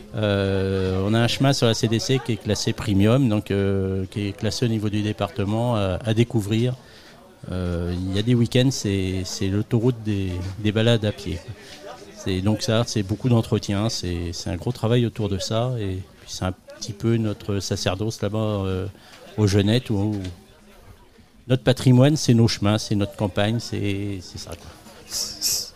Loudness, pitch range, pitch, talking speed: -23 LUFS, 100-115 Hz, 105 Hz, 175 wpm